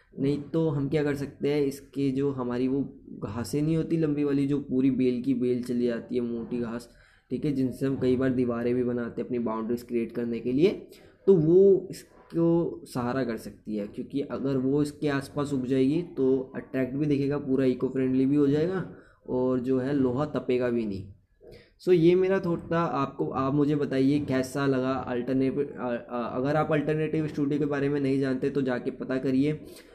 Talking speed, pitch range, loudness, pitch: 195 wpm, 125-145 Hz, -27 LUFS, 135 Hz